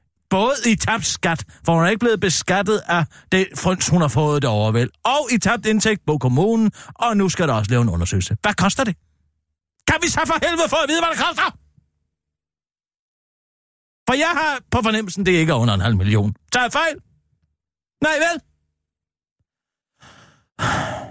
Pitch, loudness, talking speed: 170 Hz, -19 LUFS, 175 wpm